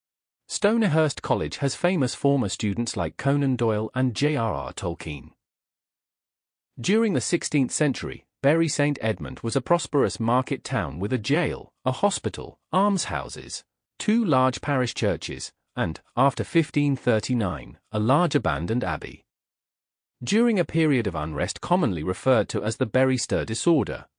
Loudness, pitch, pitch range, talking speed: -25 LUFS, 130 Hz, 110-150 Hz, 140 wpm